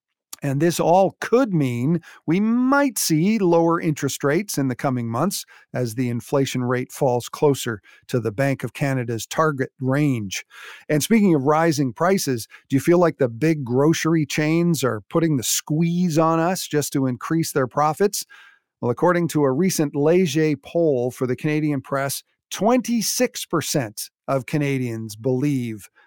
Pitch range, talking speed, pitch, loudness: 130-170 Hz, 155 wpm, 150 Hz, -21 LUFS